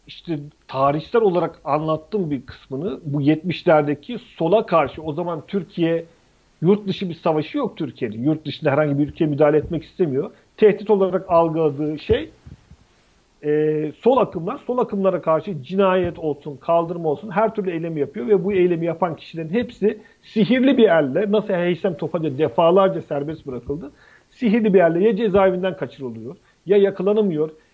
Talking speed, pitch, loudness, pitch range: 145 wpm, 170 Hz, -20 LUFS, 150-200 Hz